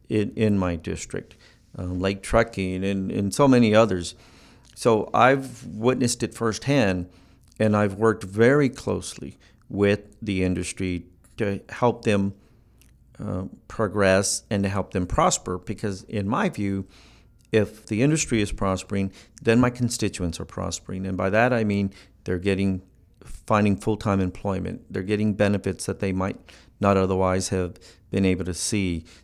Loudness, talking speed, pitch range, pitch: -24 LUFS, 150 wpm, 95-110 Hz, 100 Hz